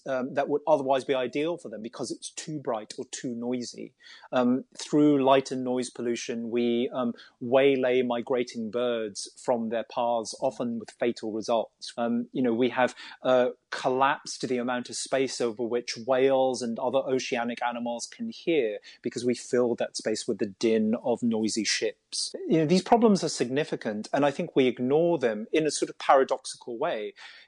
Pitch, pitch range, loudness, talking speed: 125 Hz, 120-145 Hz, -27 LUFS, 180 wpm